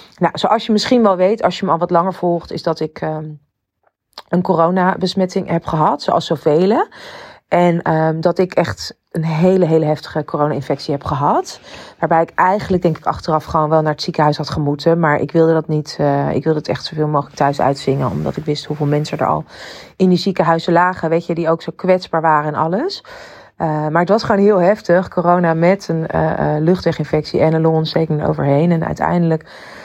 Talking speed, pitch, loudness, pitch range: 205 wpm, 165 Hz, -16 LUFS, 155-180 Hz